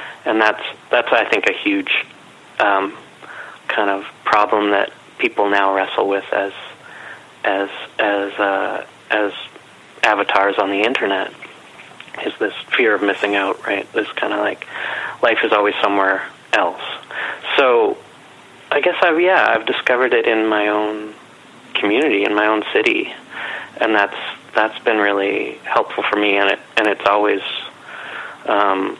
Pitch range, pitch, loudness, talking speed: 100-110 Hz, 105 Hz, -17 LUFS, 145 wpm